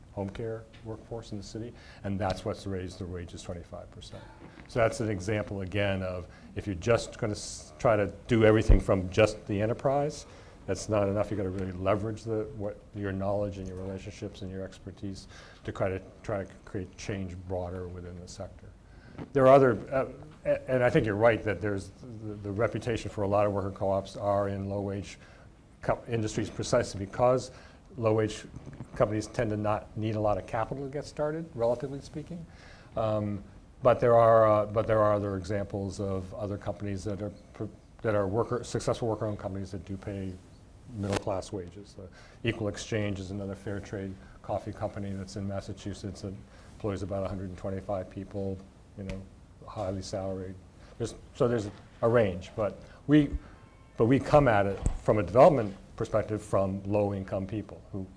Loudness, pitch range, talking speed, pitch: -30 LUFS, 95-110 Hz, 180 wpm, 100 Hz